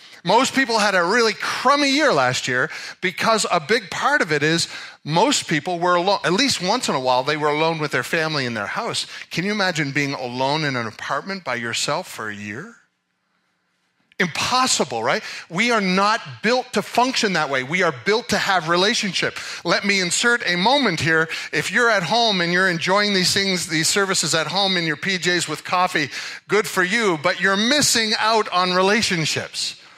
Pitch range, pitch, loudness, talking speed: 150-210 Hz, 180 Hz, -19 LUFS, 195 wpm